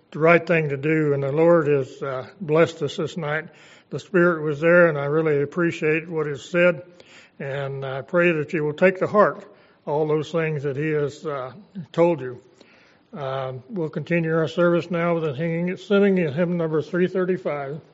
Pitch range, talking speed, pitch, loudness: 145-175 Hz, 185 wpm, 160 Hz, -22 LUFS